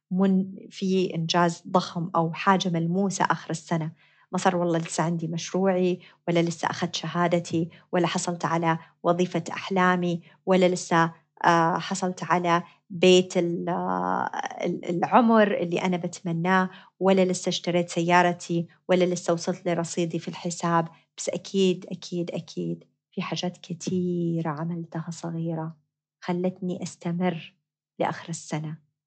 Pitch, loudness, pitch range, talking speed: 175 Hz, -26 LUFS, 165-185 Hz, 115 wpm